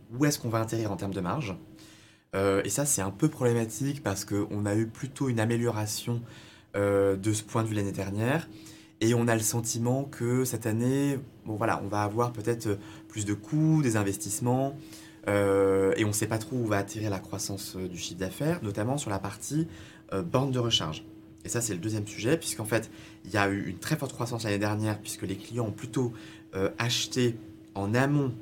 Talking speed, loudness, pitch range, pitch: 210 wpm, -29 LUFS, 105-120 Hz, 110 Hz